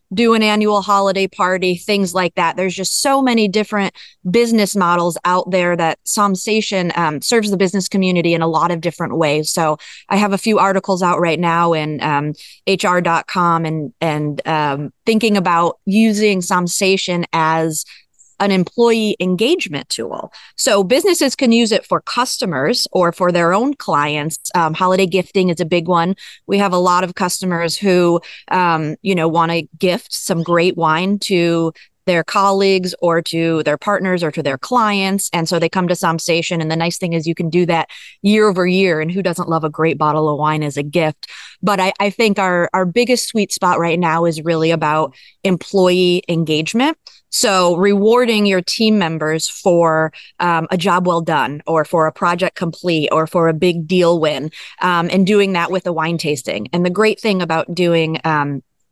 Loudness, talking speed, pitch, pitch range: -16 LUFS, 185 wpm, 180 Hz, 165-195 Hz